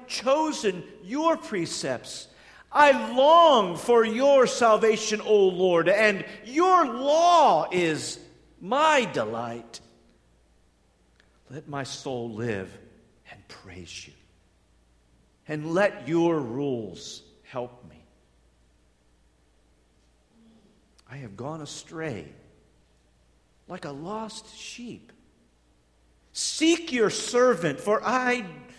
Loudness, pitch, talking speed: -23 LUFS, 155 Hz, 90 wpm